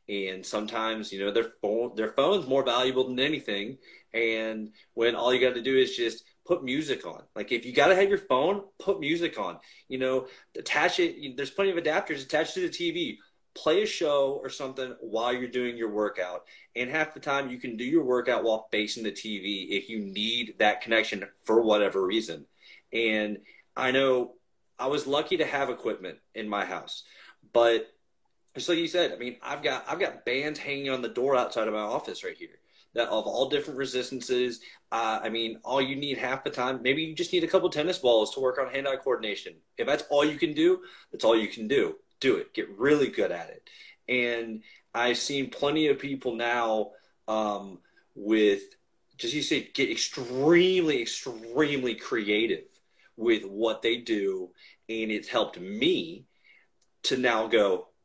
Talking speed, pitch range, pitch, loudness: 190 wpm, 115-180 Hz, 130 Hz, -28 LUFS